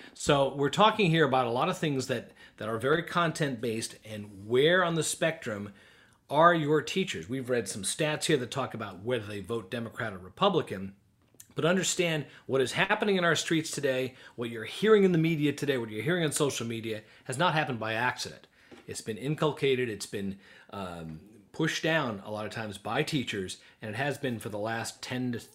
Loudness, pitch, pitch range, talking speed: -29 LUFS, 130 Hz, 110-155 Hz, 200 wpm